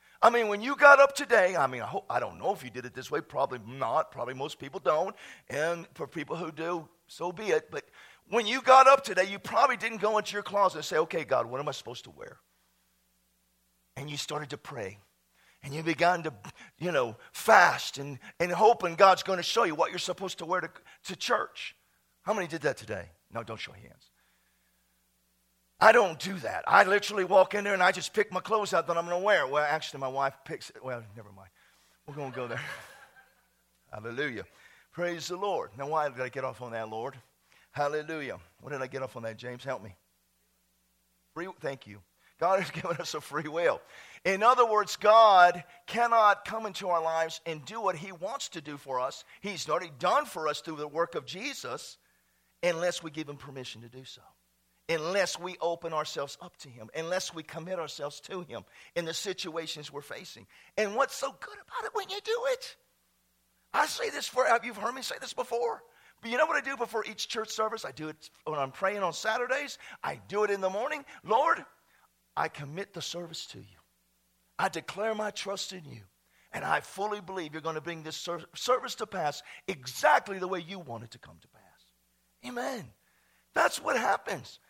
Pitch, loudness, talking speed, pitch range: 170 Hz, -29 LUFS, 215 wpm, 130-205 Hz